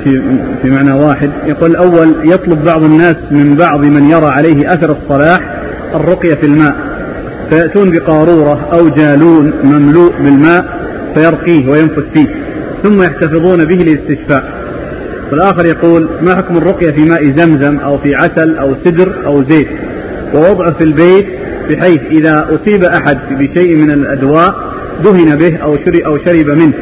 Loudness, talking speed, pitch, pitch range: -8 LUFS, 140 wpm, 160 Hz, 145-170 Hz